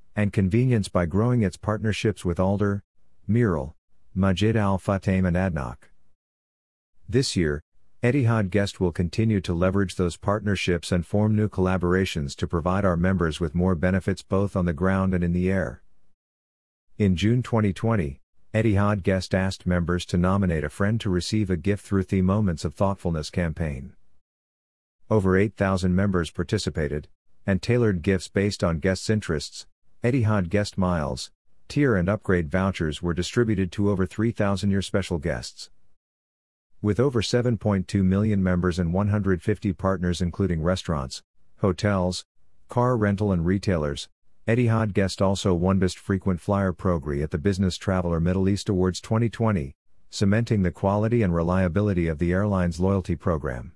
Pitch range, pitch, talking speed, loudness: 90-105 Hz, 95 Hz, 145 wpm, -24 LUFS